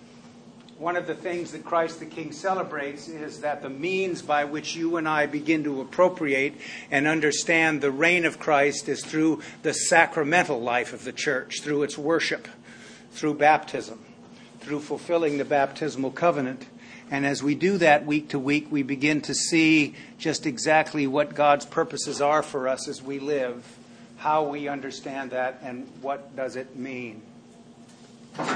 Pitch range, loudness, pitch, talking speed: 140-160 Hz, -25 LUFS, 150 Hz, 160 wpm